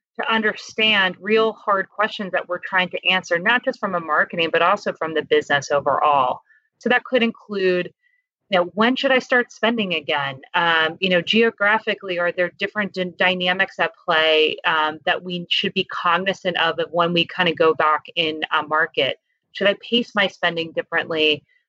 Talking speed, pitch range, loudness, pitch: 185 wpm, 165-210 Hz, -20 LUFS, 180 Hz